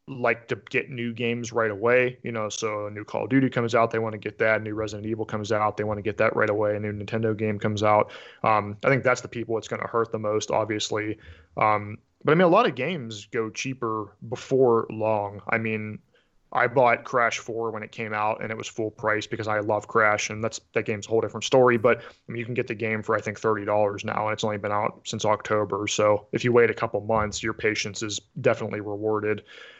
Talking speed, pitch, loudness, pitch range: 255 wpm, 110 Hz, -25 LUFS, 105-115 Hz